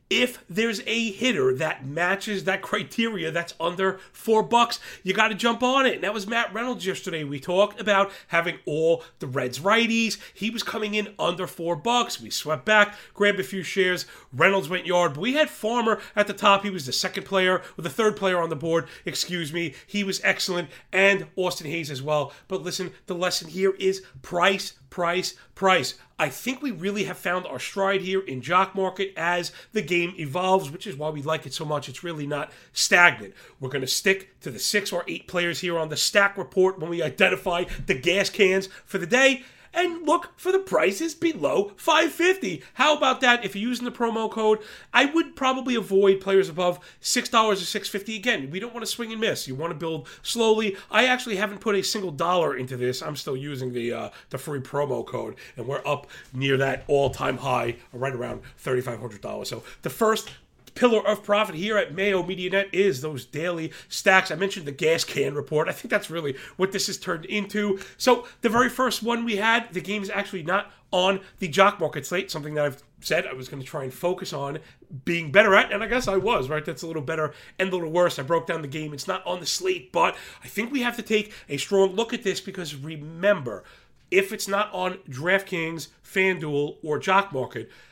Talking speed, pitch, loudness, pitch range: 215 wpm, 190 Hz, -24 LUFS, 160-210 Hz